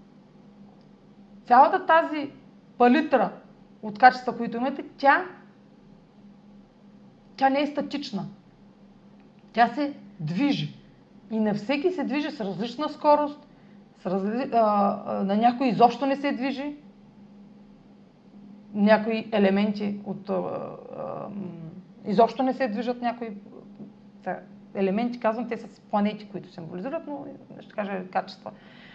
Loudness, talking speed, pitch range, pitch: -25 LUFS, 105 wpm, 205-250 Hz, 210 Hz